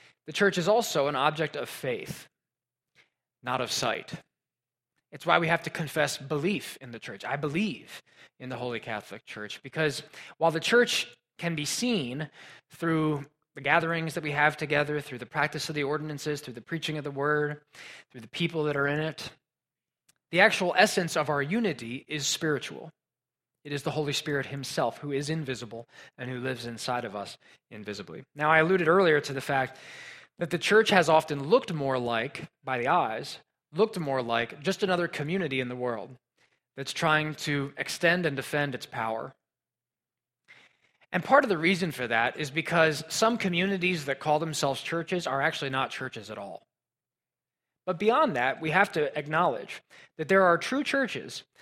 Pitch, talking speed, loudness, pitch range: 150 Hz, 180 wpm, -28 LUFS, 135-170 Hz